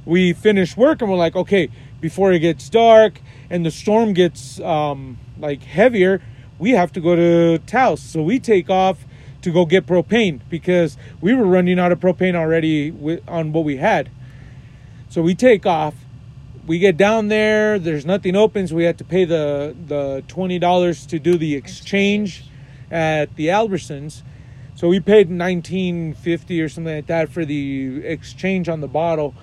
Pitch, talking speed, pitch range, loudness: 165 Hz, 175 wpm, 145-185 Hz, -17 LUFS